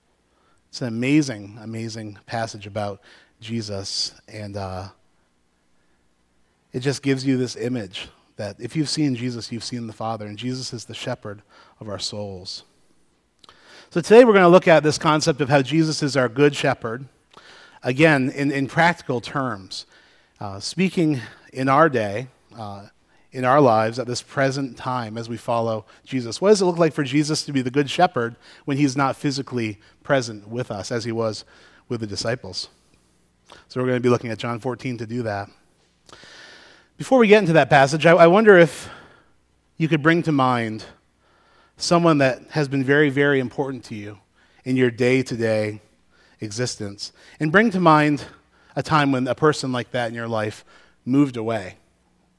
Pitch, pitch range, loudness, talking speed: 125 Hz, 110-145 Hz, -20 LUFS, 175 wpm